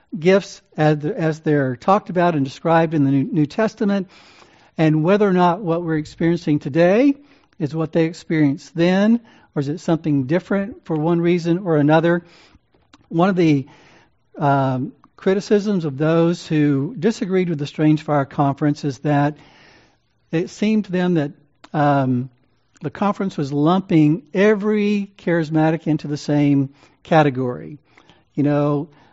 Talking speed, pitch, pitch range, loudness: 140 wpm, 160 Hz, 145-185 Hz, -19 LUFS